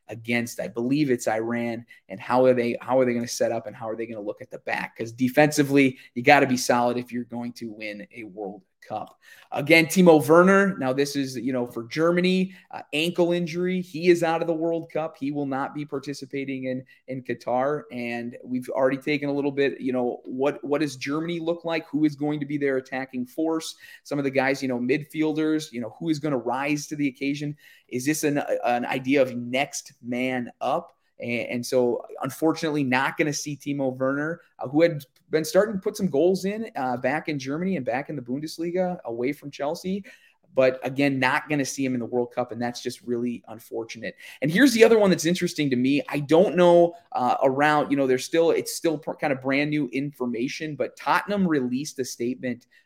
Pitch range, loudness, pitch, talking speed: 125-160 Hz, -24 LUFS, 140 Hz, 220 wpm